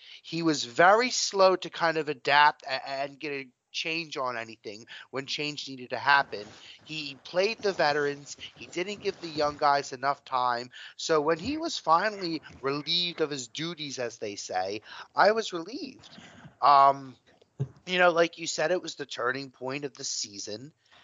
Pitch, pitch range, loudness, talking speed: 145 Hz, 135-165 Hz, -27 LUFS, 170 wpm